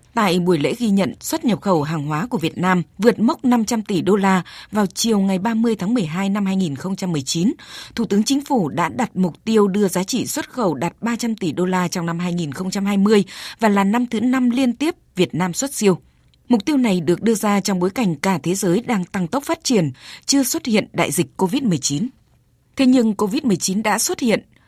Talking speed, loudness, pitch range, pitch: 215 wpm, -19 LUFS, 180-235 Hz, 200 Hz